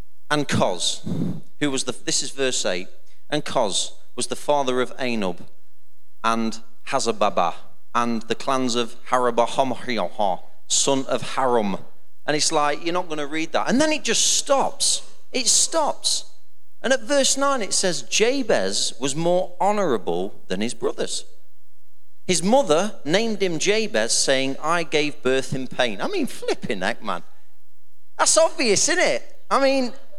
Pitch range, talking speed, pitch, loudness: 130-220 Hz, 155 wpm, 155 Hz, -22 LUFS